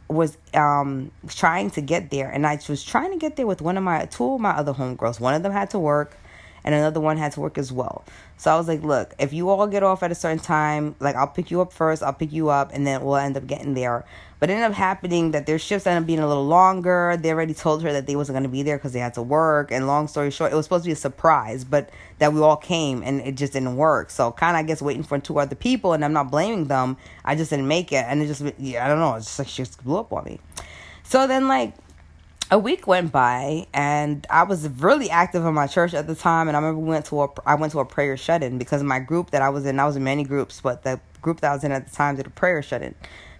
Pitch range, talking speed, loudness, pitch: 135-165 Hz, 295 wpm, -22 LUFS, 150 Hz